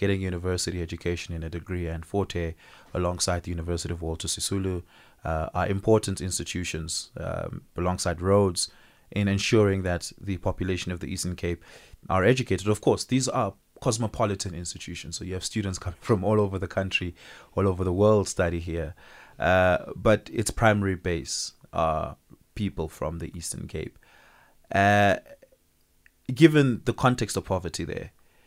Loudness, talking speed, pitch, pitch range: -27 LUFS, 150 wpm, 95 Hz, 85-100 Hz